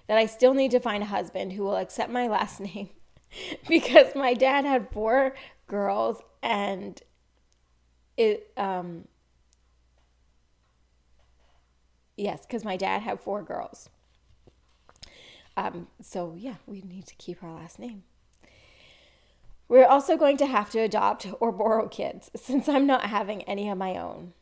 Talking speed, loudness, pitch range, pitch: 145 wpm, -25 LUFS, 165-250 Hz, 200 Hz